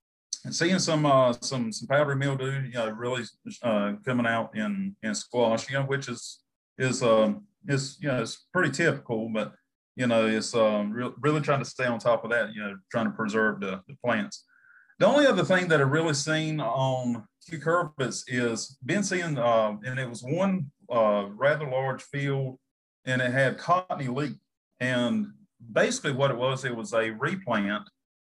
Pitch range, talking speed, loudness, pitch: 115-150 Hz, 190 wpm, -27 LUFS, 130 Hz